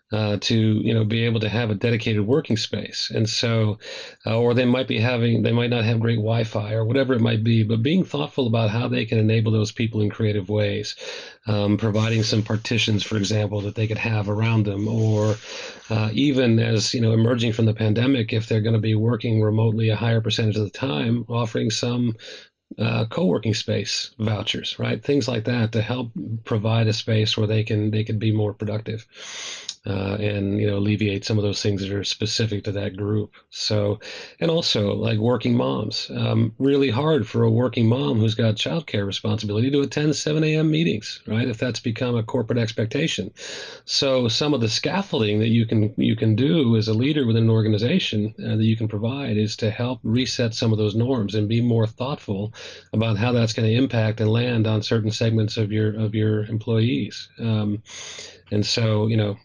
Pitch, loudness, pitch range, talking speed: 110 Hz, -22 LUFS, 105-120 Hz, 205 wpm